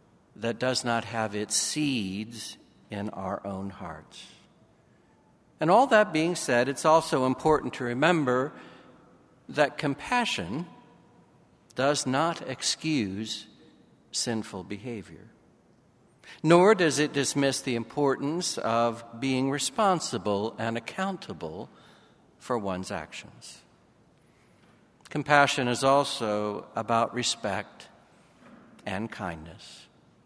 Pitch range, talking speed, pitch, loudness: 110-150 Hz, 95 wpm, 125 Hz, -27 LUFS